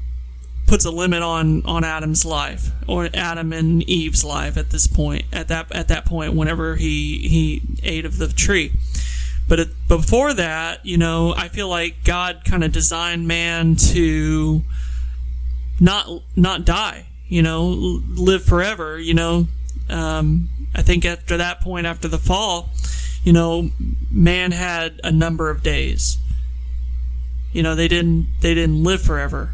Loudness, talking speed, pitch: -19 LUFS, 155 wpm, 155 Hz